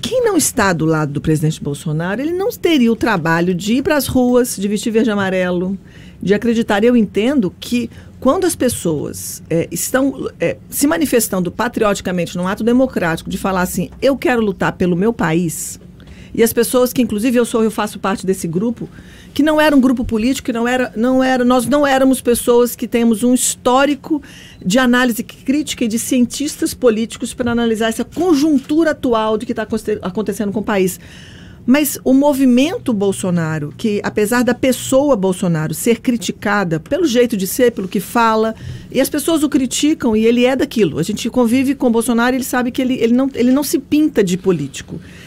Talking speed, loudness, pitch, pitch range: 190 wpm, -16 LUFS, 235 Hz, 205-260 Hz